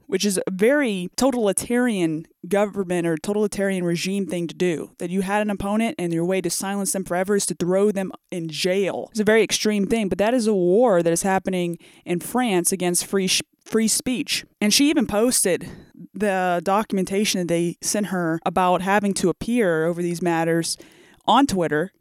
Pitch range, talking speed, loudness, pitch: 175-210 Hz, 190 wpm, -21 LUFS, 190 Hz